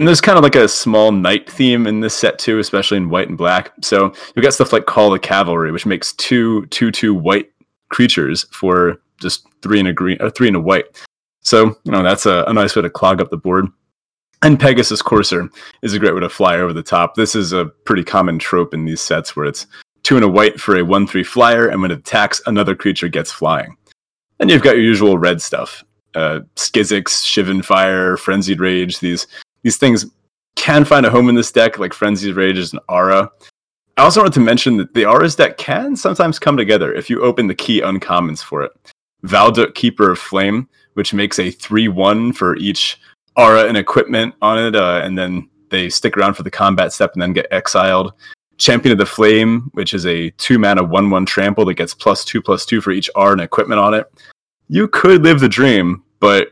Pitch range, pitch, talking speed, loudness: 90-115 Hz, 100 Hz, 215 wpm, -13 LUFS